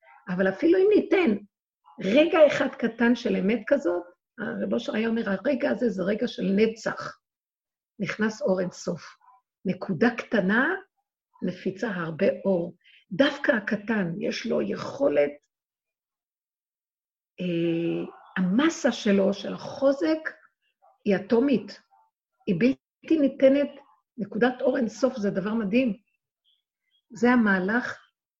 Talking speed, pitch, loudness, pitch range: 110 wpm, 230 Hz, -25 LUFS, 195-275 Hz